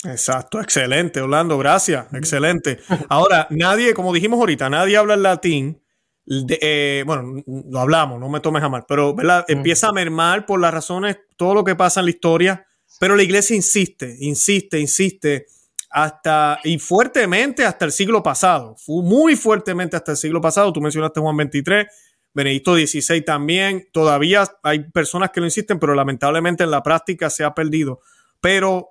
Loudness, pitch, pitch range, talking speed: -17 LUFS, 165 Hz, 150-190 Hz, 170 wpm